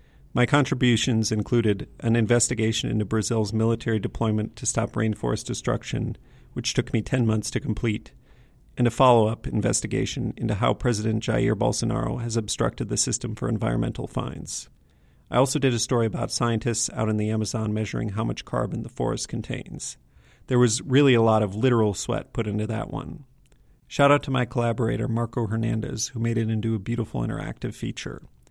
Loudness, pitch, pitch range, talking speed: -25 LUFS, 115 Hz, 110-125 Hz, 175 wpm